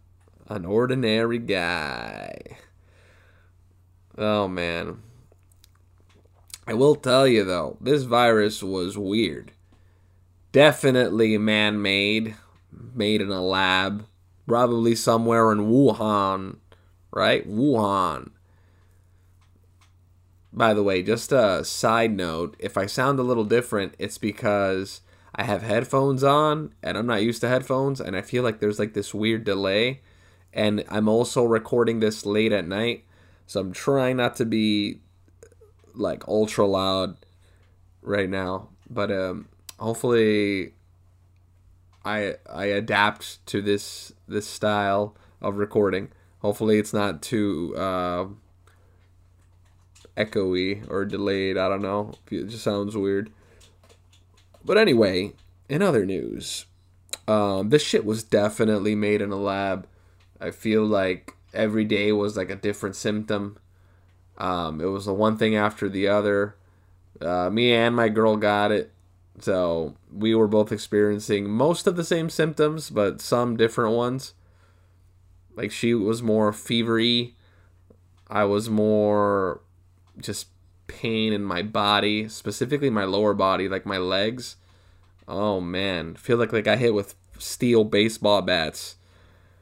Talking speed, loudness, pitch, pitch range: 130 wpm, -23 LUFS, 100 Hz, 90-110 Hz